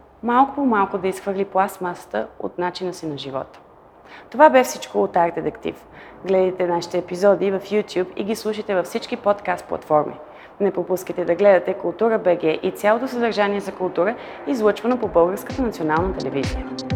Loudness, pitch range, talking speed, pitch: -21 LUFS, 175-210 Hz, 160 wpm, 190 Hz